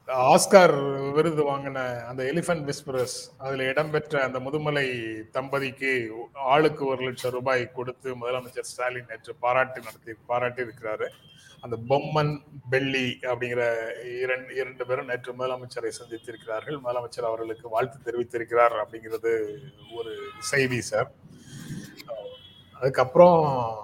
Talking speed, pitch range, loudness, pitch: 105 wpm, 120-140 Hz, -26 LUFS, 130 Hz